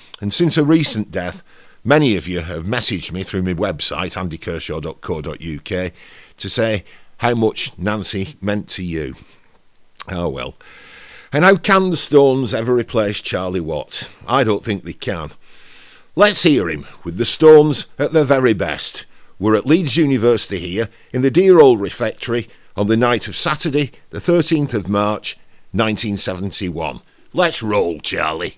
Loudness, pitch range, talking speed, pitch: -17 LUFS, 95-145 Hz, 150 wpm, 110 Hz